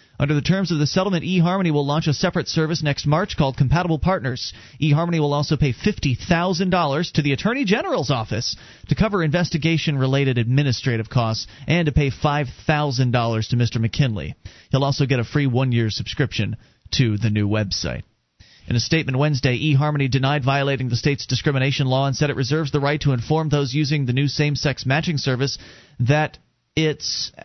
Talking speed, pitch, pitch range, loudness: 175 wpm, 140 Hz, 125-155 Hz, -21 LUFS